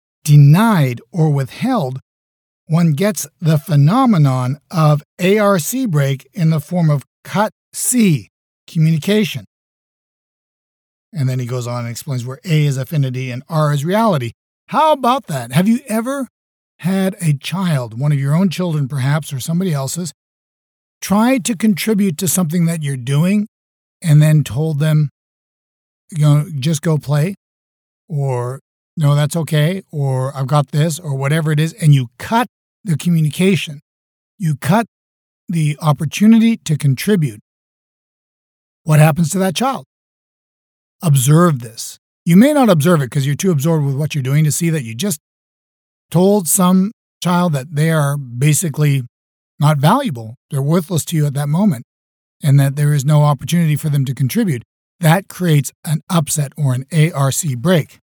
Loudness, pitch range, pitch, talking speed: -16 LUFS, 140-180 Hz, 155 Hz, 155 wpm